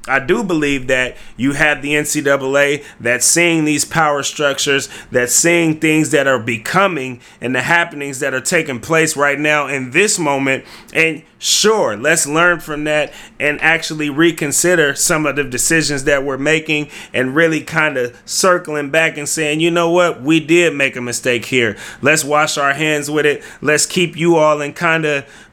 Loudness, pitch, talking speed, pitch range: -14 LUFS, 150 Hz, 180 wpm, 140-160 Hz